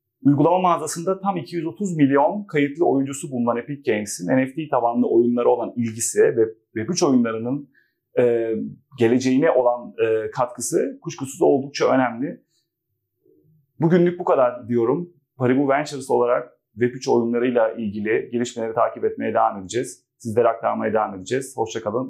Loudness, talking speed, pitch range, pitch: -21 LUFS, 125 wpm, 120-165 Hz, 130 Hz